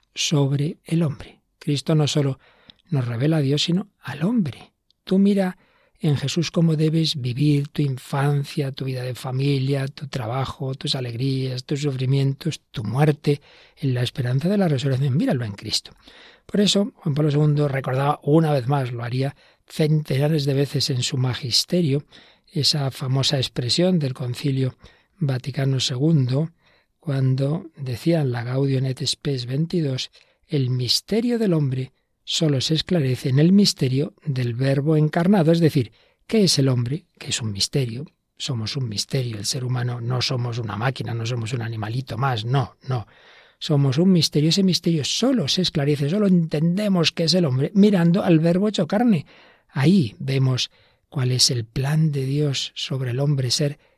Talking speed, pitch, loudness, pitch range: 160 wpm, 140 Hz, -22 LUFS, 130-160 Hz